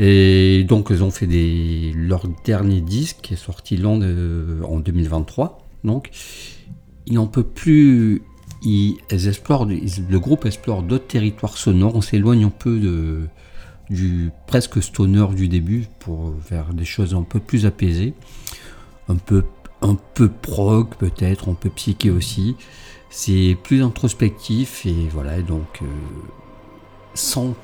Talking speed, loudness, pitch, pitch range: 135 wpm, -19 LUFS, 100 Hz, 85-110 Hz